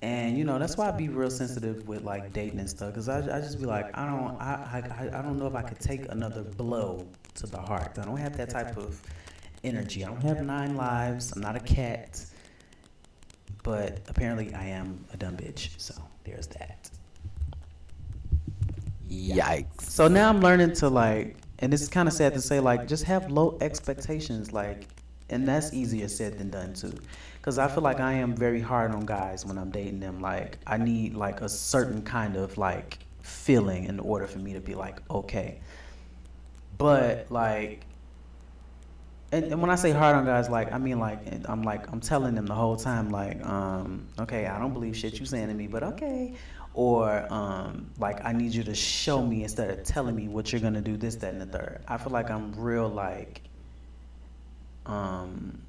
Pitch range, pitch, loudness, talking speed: 95-125 Hz, 105 Hz, -29 LUFS, 200 wpm